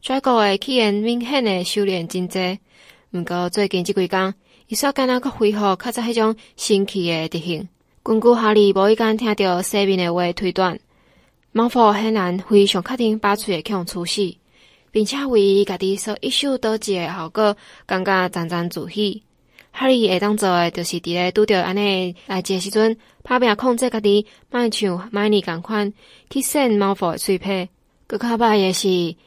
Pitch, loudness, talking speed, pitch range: 200 Hz, -19 LUFS, 255 characters per minute, 185-220 Hz